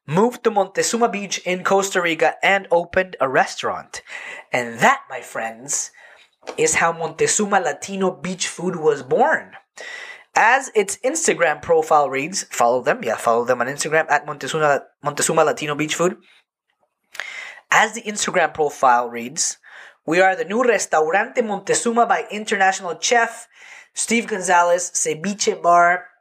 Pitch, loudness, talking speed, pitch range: 190 Hz, -19 LUFS, 135 wpm, 165-230 Hz